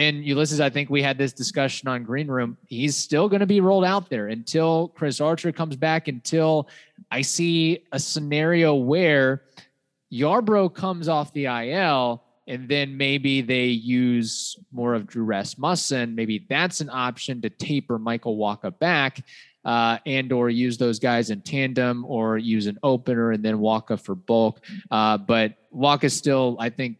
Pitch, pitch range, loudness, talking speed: 135 Hz, 120-150 Hz, -23 LUFS, 170 wpm